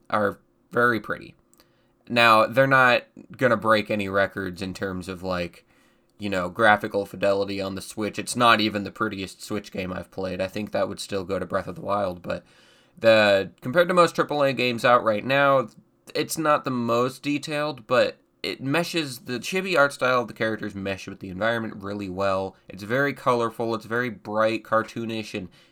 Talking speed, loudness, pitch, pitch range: 190 wpm, -24 LUFS, 110 Hz, 100-125 Hz